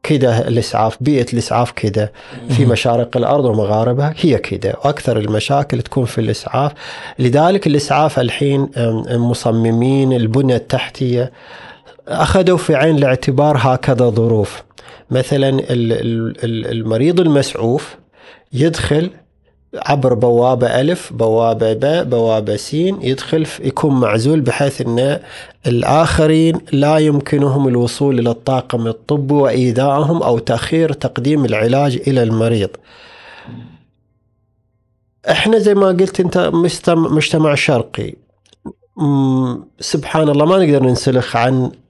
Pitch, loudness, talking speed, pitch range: 130 Hz, -15 LUFS, 105 wpm, 115-150 Hz